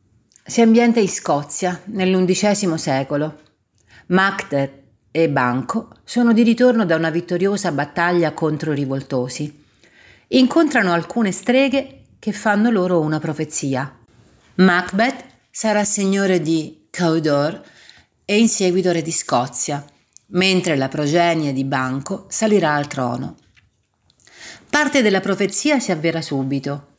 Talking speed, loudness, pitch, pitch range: 110 wpm, -18 LUFS, 170 Hz, 145-205 Hz